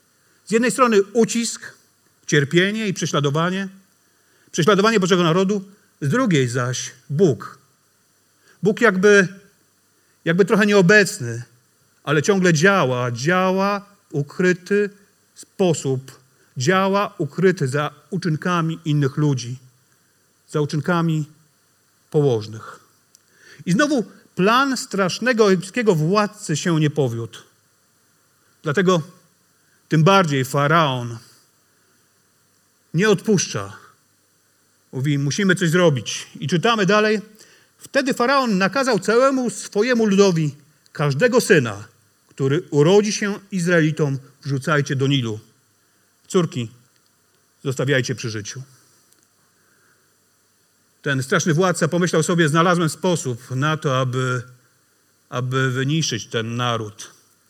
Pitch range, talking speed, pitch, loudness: 135-200 Hz, 95 wpm, 160 Hz, -19 LUFS